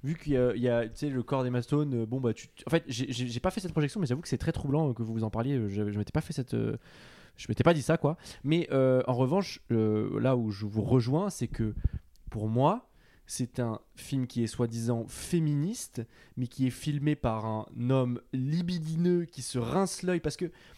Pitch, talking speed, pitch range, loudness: 130 Hz, 235 wpm, 120-155 Hz, -30 LUFS